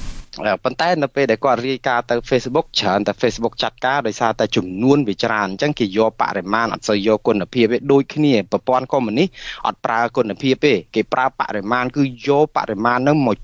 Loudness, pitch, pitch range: -18 LUFS, 125 Hz, 110-140 Hz